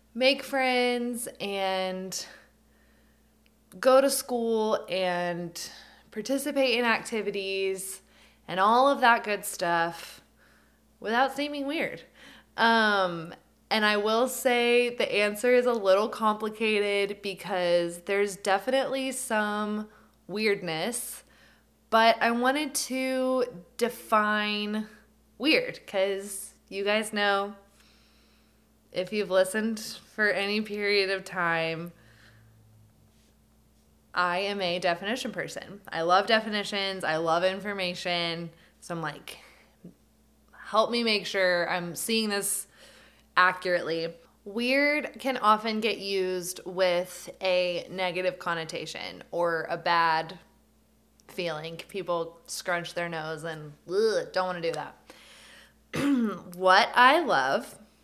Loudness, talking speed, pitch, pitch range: -27 LUFS, 105 wpm, 200 Hz, 175-230 Hz